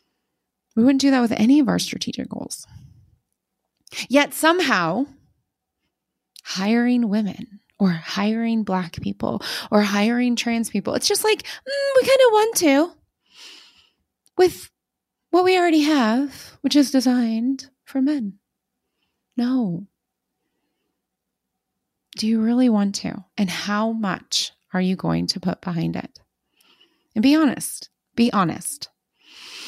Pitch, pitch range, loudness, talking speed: 240 Hz, 205-285 Hz, -20 LUFS, 125 wpm